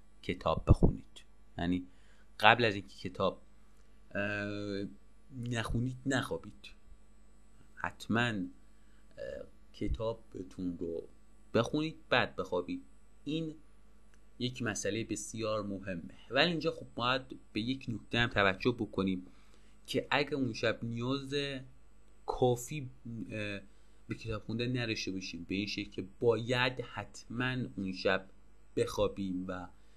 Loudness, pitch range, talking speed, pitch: -35 LUFS, 100-125 Hz, 100 wpm, 115 Hz